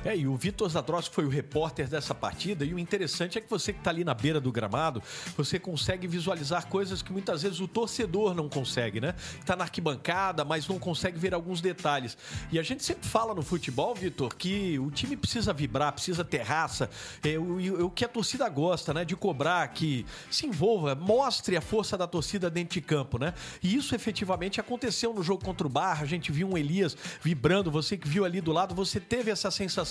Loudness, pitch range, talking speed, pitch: -30 LUFS, 150-195 Hz, 215 wpm, 175 Hz